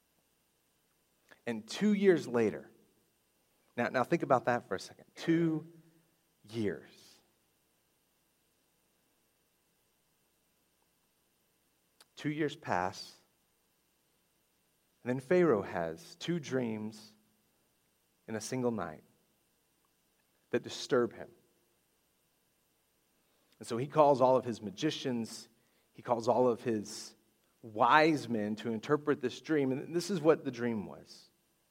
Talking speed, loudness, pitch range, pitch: 105 wpm, -32 LUFS, 110-155 Hz, 125 Hz